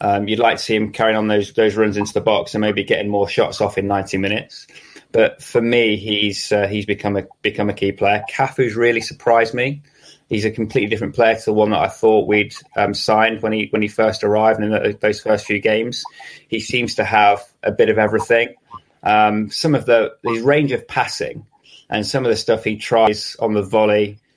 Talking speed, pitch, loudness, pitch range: 225 wpm, 110 Hz, -17 LUFS, 105-115 Hz